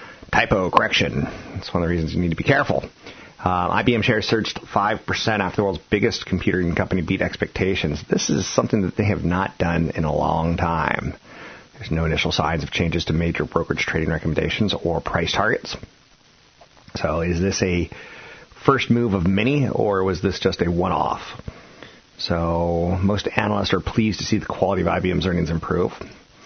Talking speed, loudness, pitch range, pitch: 175 wpm, -21 LUFS, 85-105 Hz, 95 Hz